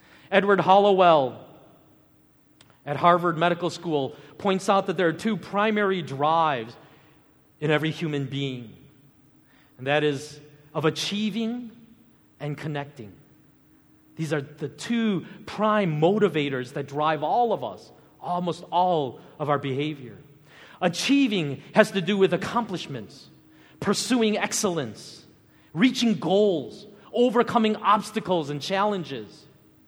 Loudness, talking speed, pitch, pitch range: -24 LUFS, 110 wpm, 165 Hz, 145-205 Hz